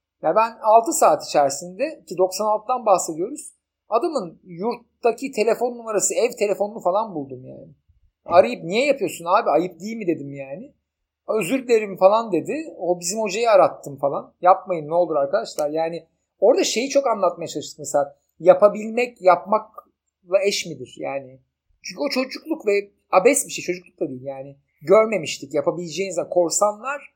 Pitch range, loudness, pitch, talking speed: 165-230 Hz, -21 LUFS, 190 Hz, 145 wpm